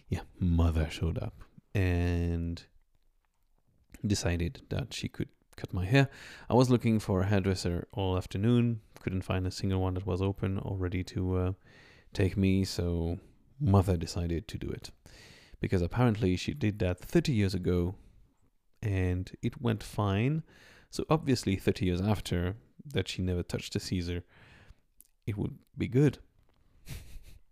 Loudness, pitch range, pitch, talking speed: -31 LUFS, 90-110 Hz, 95 Hz, 145 wpm